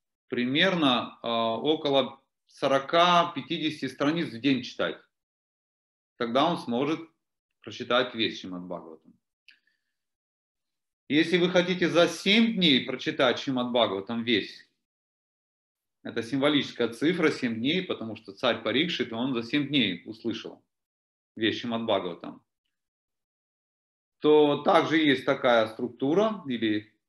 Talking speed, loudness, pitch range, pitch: 105 wpm, -26 LUFS, 115-155 Hz, 130 Hz